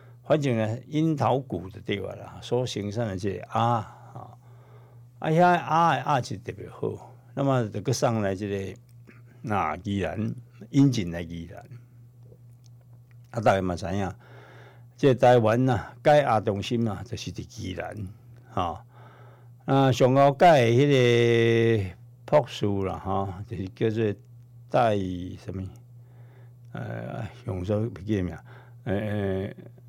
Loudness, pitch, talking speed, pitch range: -25 LUFS, 120 Hz, 190 characters per minute, 105-125 Hz